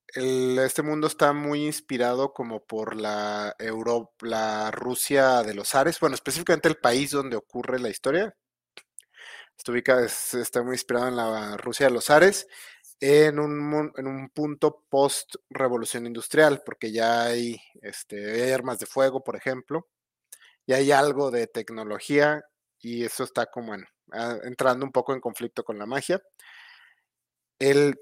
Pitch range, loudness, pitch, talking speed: 120-145 Hz, -25 LUFS, 130 Hz, 150 wpm